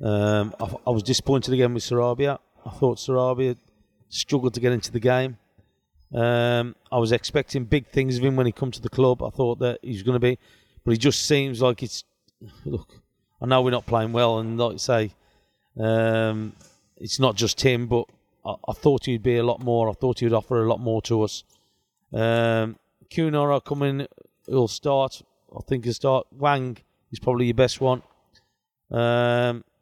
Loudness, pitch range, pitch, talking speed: -23 LUFS, 115-130 Hz, 120 Hz, 195 wpm